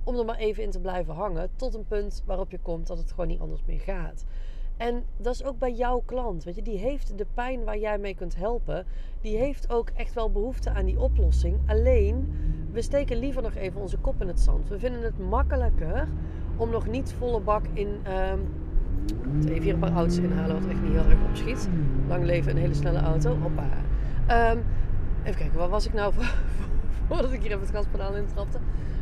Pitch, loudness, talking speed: 175 Hz, -29 LUFS, 215 wpm